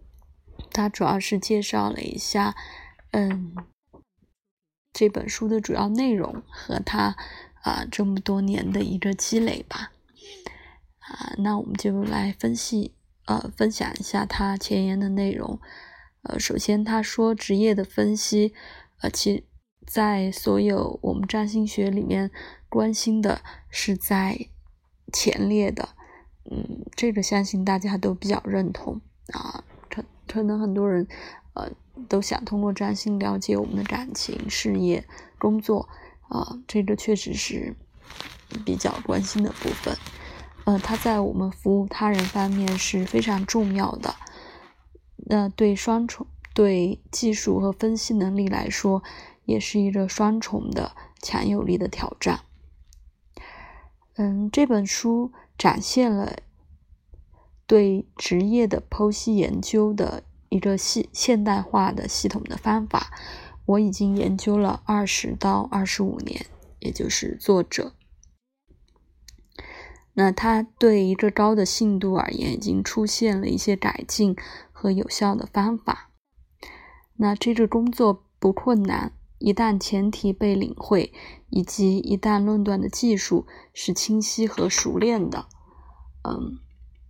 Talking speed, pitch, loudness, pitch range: 190 characters per minute, 200 Hz, -24 LUFS, 190-215 Hz